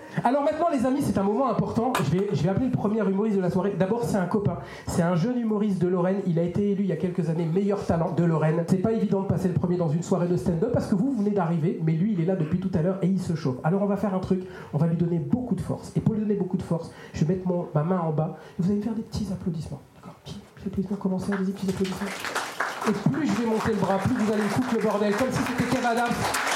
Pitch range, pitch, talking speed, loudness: 175-210 Hz, 190 Hz, 290 wpm, -25 LUFS